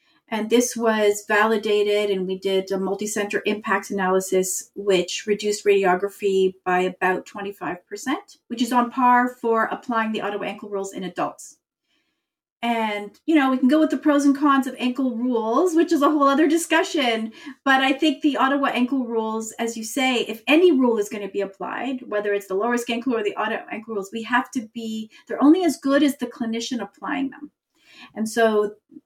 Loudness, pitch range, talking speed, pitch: -22 LUFS, 205-275 Hz, 195 wpm, 230 Hz